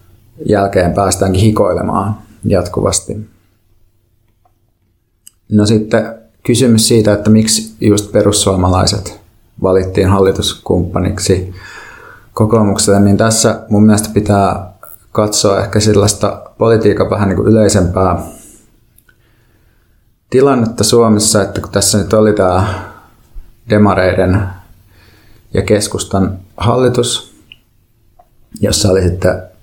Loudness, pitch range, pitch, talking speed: -12 LUFS, 95-110 Hz, 105 Hz, 90 wpm